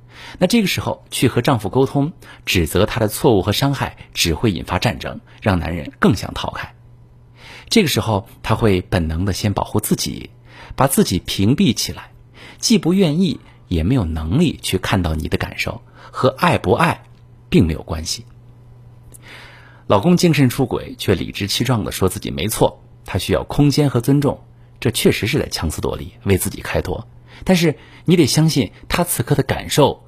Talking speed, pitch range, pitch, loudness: 260 characters per minute, 100-135 Hz, 120 Hz, -18 LUFS